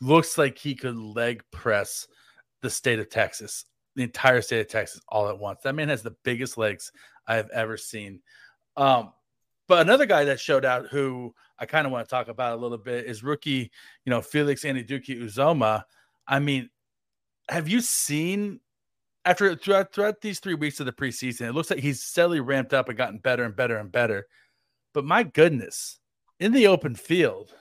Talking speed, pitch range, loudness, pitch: 190 wpm, 120-160 Hz, -25 LUFS, 135 Hz